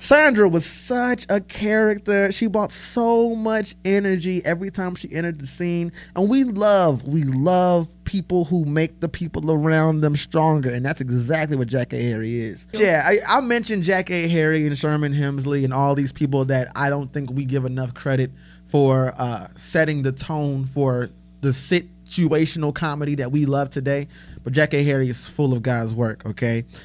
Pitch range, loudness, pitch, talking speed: 135-180 Hz, -21 LUFS, 150 Hz, 185 wpm